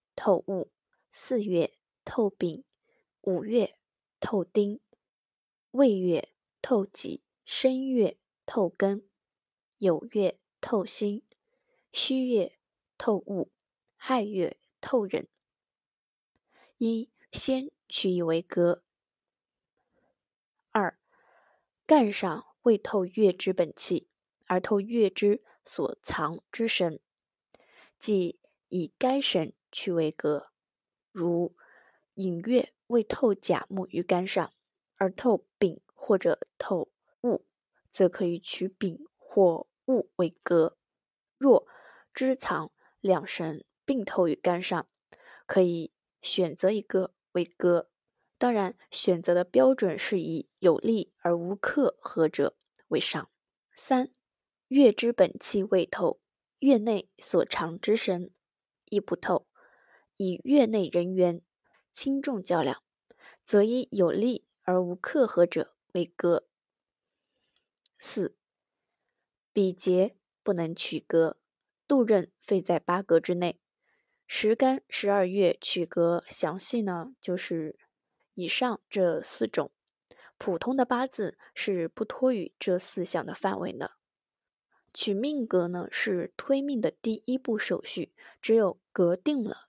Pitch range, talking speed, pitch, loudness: 175-245 Hz, 150 characters per minute, 195 Hz, -28 LUFS